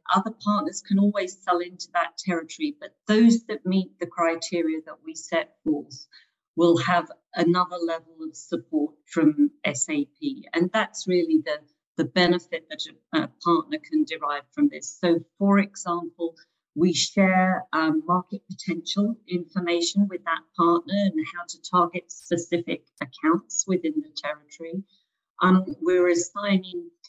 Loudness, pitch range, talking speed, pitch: -25 LUFS, 170-215 Hz, 140 wpm, 180 Hz